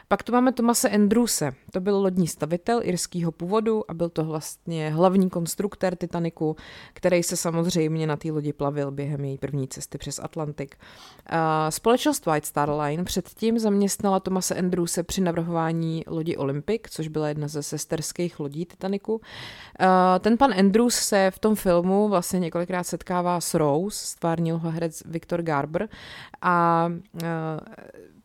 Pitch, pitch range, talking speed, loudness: 170 Hz, 155-190 Hz, 150 wpm, -24 LUFS